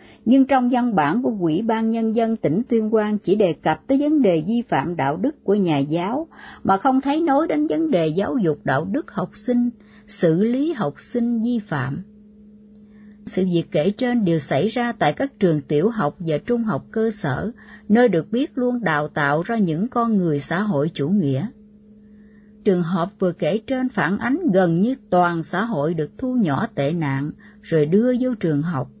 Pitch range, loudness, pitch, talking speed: 170-235 Hz, -21 LUFS, 210 Hz, 200 wpm